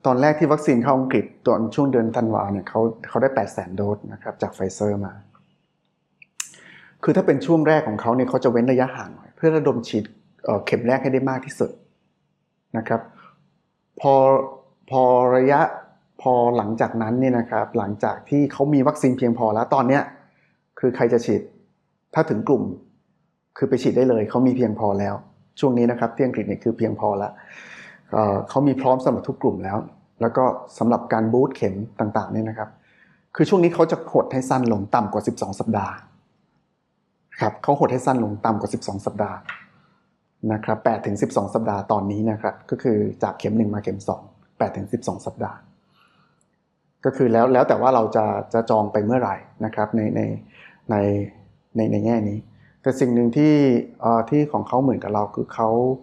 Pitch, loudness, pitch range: 115 Hz, -21 LUFS, 110-130 Hz